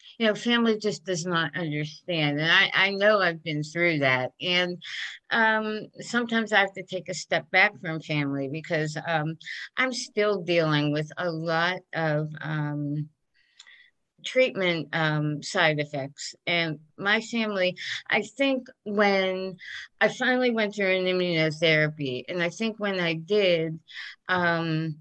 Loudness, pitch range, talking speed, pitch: -25 LUFS, 155-205 Hz, 145 wpm, 175 Hz